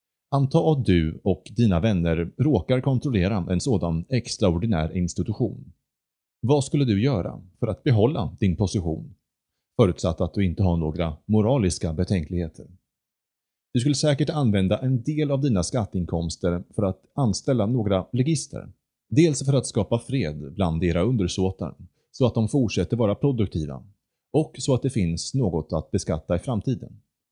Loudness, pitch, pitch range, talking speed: -24 LUFS, 100 Hz, 90-130 Hz, 145 wpm